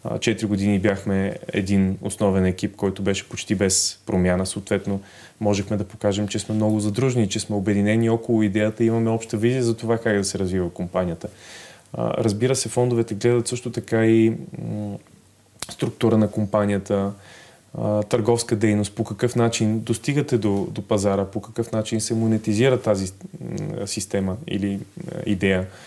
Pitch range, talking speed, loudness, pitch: 100-115 Hz, 145 wpm, -22 LUFS, 105 Hz